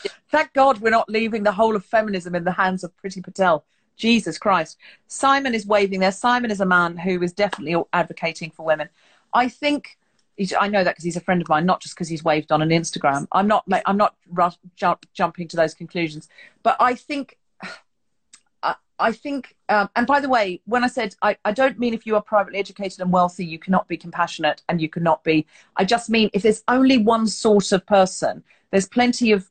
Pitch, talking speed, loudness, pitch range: 195 Hz, 220 wpm, -21 LUFS, 175-225 Hz